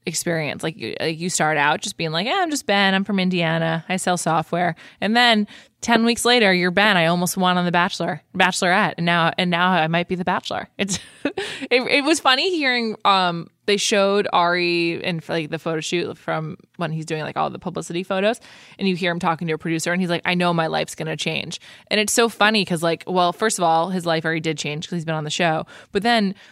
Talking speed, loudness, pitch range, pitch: 240 wpm, -20 LUFS, 165-205 Hz, 180 Hz